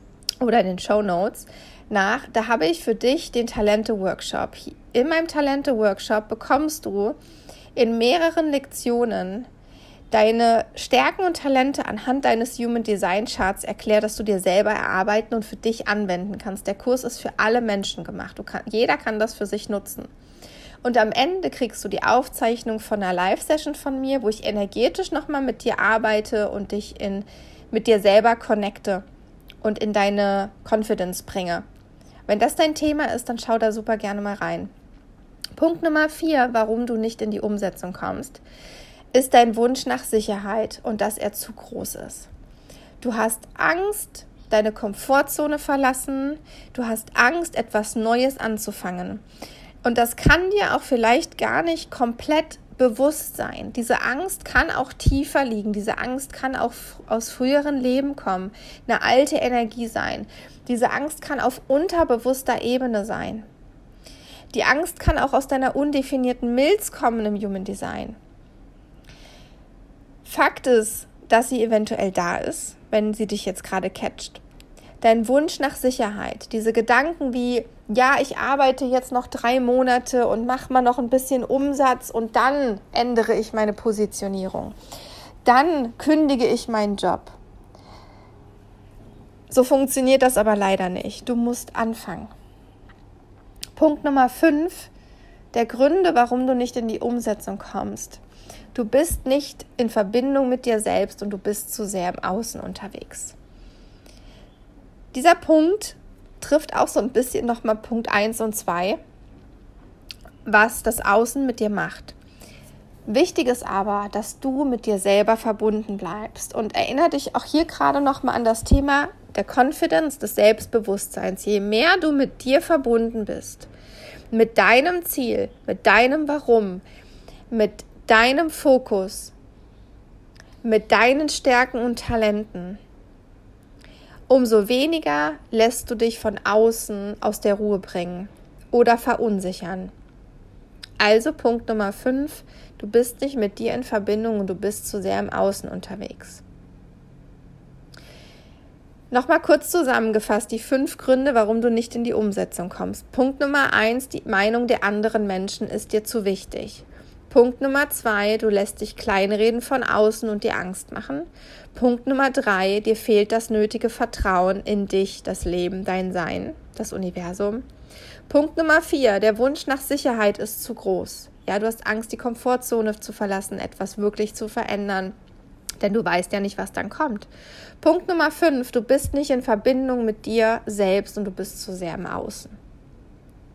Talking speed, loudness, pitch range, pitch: 150 wpm, -22 LUFS, 205-260 Hz, 225 Hz